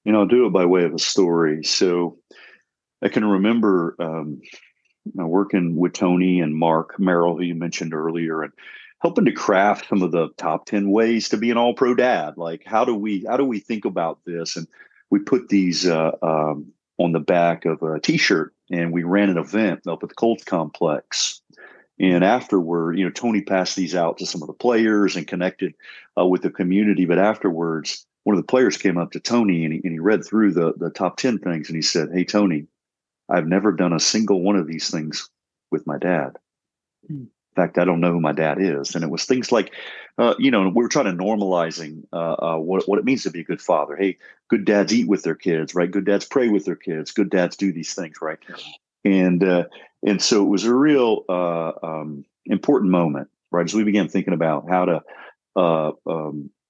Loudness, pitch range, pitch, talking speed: -20 LUFS, 85-100 Hz, 90 Hz, 215 wpm